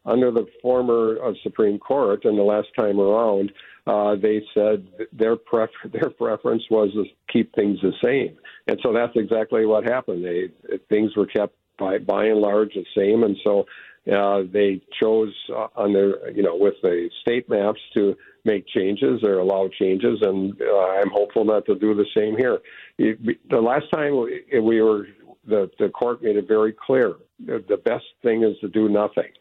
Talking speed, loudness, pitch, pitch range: 180 wpm, -21 LUFS, 105 Hz, 100-115 Hz